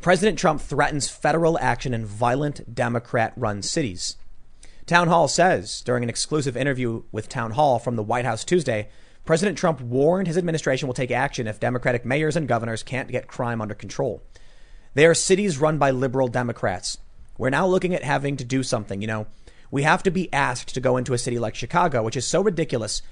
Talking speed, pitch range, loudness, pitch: 195 wpm, 115-155 Hz, -23 LUFS, 130 Hz